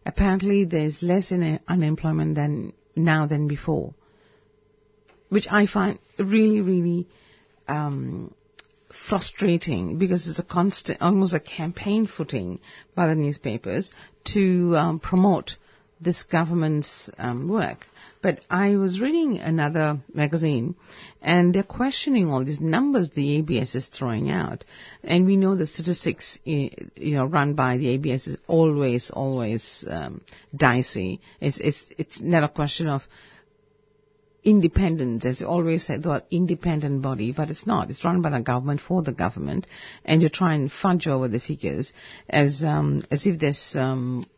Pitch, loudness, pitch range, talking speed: 160 Hz, -23 LUFS, 140-180 Hz, 145 wpm